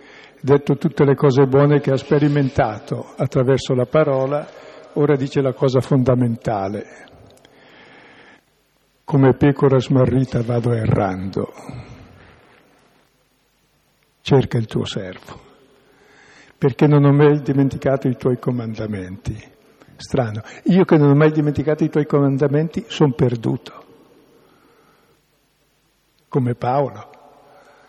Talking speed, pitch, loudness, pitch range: 100 wpm, 140 Hz, -18 LUFS, 130-150 Hz